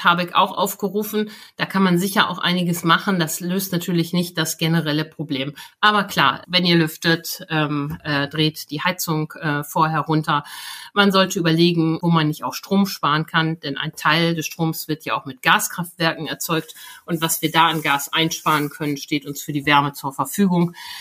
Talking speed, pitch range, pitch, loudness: 190 wpm, 150-180 Hz, 165 Hz, -20 LUFS